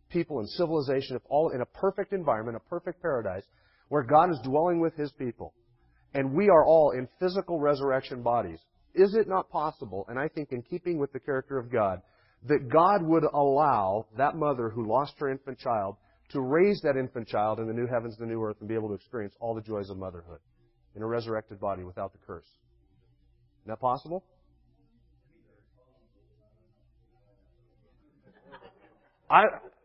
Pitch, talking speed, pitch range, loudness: 125 Hz, 175 wpm, 105-150 Hz, -28 LUFS